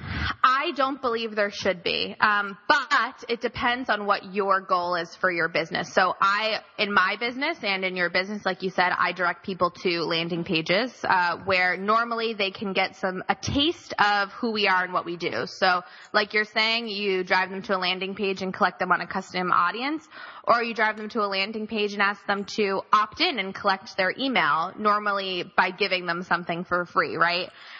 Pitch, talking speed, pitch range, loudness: 200 Hz, 210 wpm, 185-220 Hz, -24 LUFS